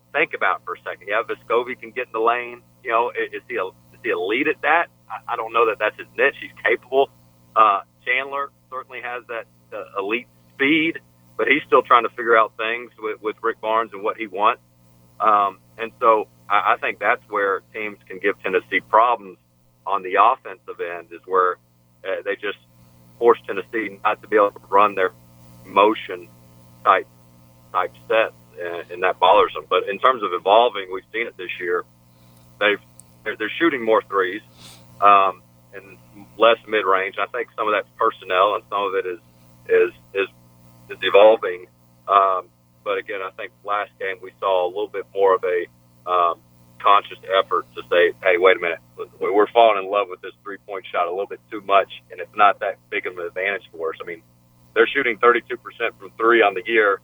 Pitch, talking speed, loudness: 85 Hz, 200 wpm, -20 LUFS